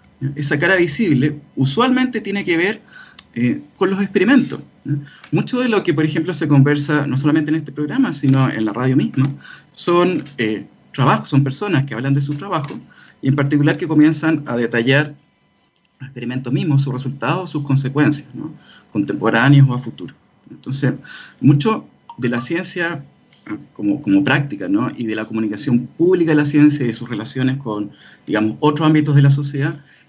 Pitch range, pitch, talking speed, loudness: 130-160 Hz, 145 Hz, 175 wpm, -17 LUFS